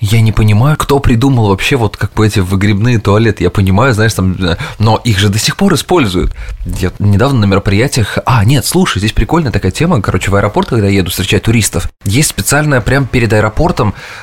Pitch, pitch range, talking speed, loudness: 110 Hz, 100-130 Hz, 200 wpm, -11 LUFS